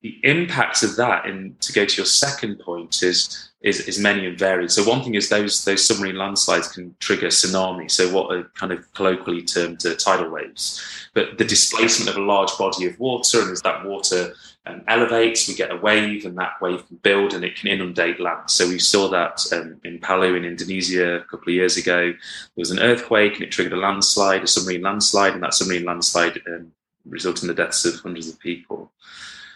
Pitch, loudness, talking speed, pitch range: 95 Hz, -19 LUFS, 215 wpm, 90-100 Hz